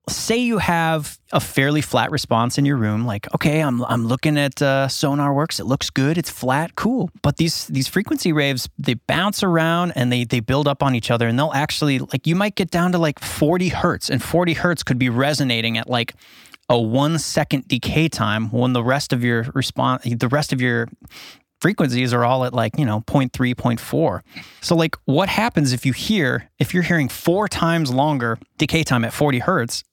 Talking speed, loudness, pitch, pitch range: 205 wpm, -19 LUFS, 140 Hz, 125-160 Hz